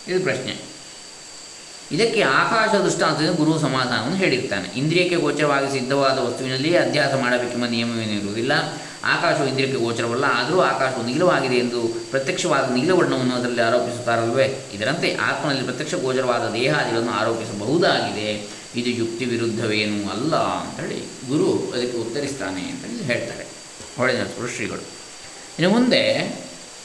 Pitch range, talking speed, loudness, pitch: 115-140 Hz, 105 wpm, -21 LUFS, 125 Hz